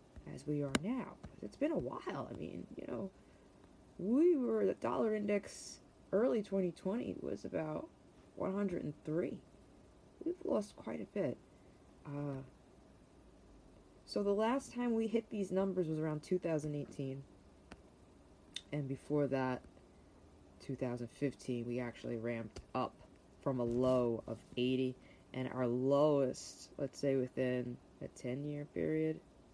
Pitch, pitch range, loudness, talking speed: 135 Hz, 120-185 Hz, -39 LUFS, 125 wpm